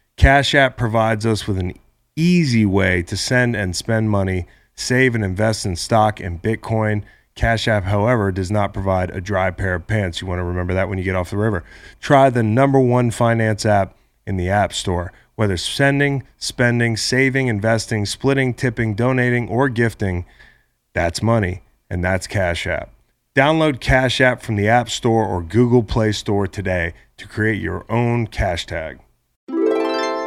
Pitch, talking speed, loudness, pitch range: 110 Hz, 170 wpm, -18 LUFS, 95-120 Hz